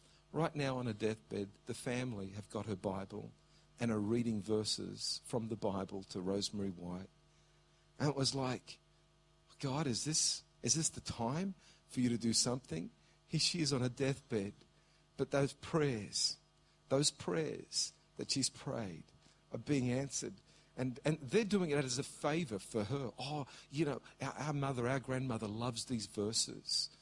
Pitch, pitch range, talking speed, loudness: 130 Hz, 110-150 Hz, 165 wpm, -38 LUFS